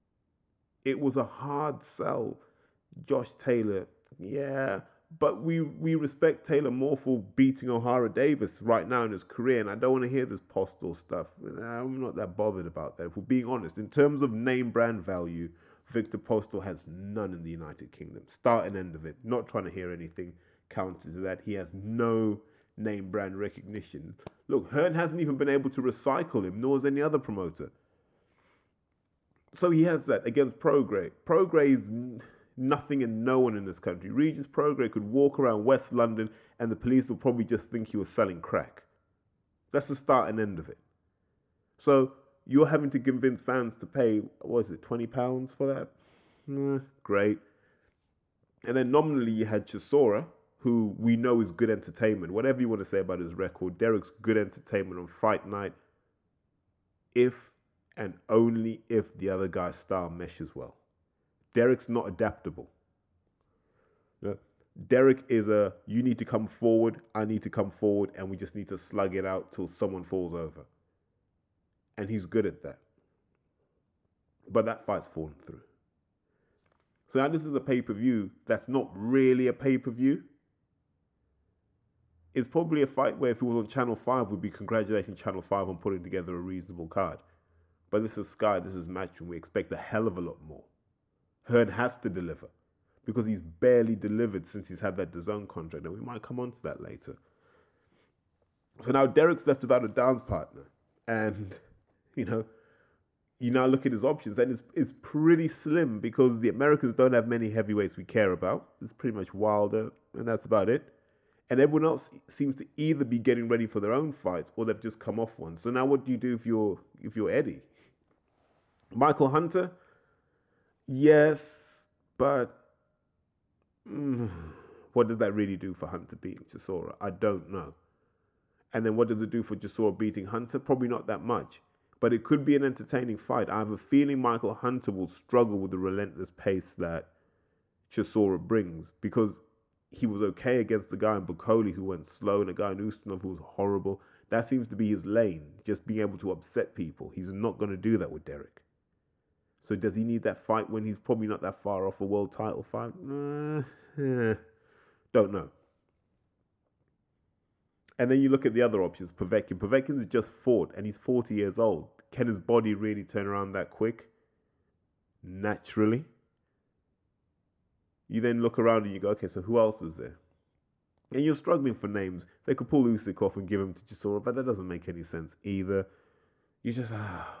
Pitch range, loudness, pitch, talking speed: 95-125 Hz, -29 LUFS, 110 Hz, 180 wpm